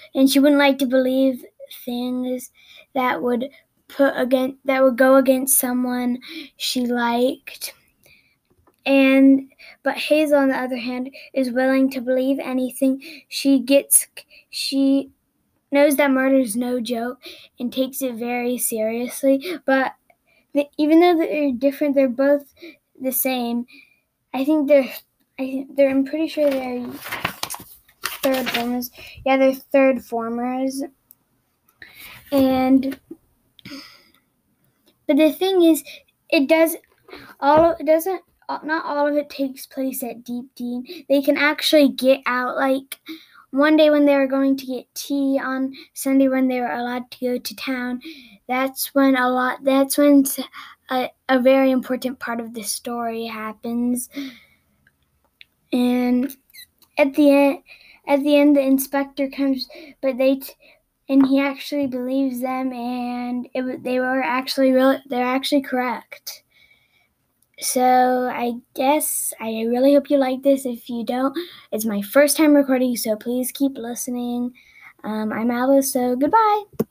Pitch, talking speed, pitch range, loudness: 270 Hz, 145 wpm, 250-285 Hz, -20 LUFS